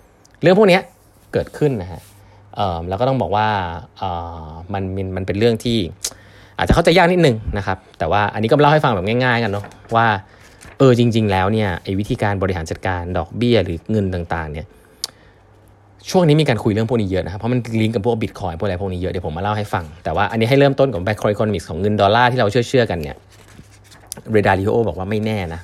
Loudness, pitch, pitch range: -18 LUFS, 105 Hz, 95-115 Hz